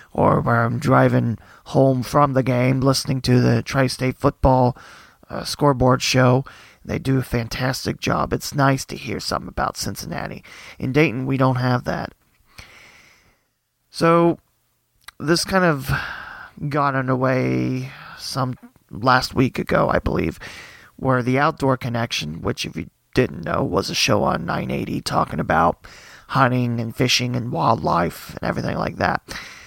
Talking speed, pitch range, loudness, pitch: 145 wpm, 125-135 Hz, -20 LUFS, 130 Hz